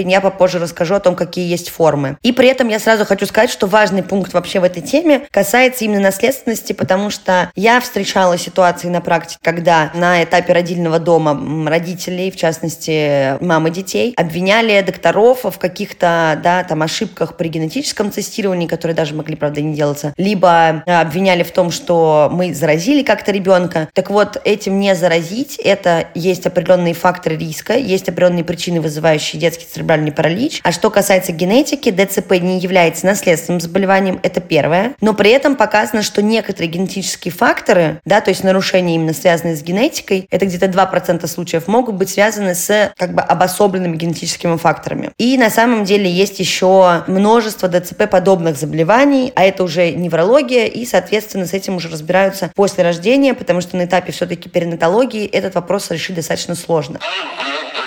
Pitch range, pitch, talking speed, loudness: 170-205 Hz, 180 Hz, 160 wpm, -14 LUFS